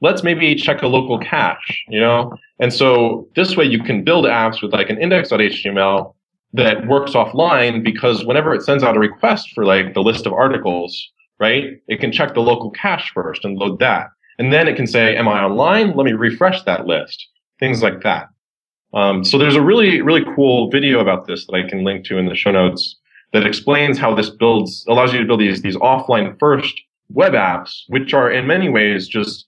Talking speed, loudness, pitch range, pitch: 210 wpm, -15 LUFS, 105-135 Hz, 115 Hz